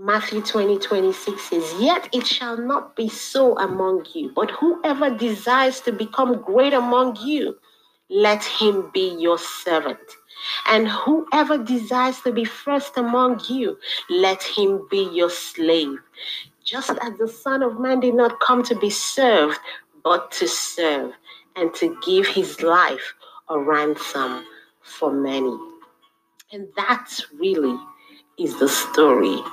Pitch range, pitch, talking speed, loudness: 190-270 Hz, 235 Hz, 140 wpm, -21 LUFS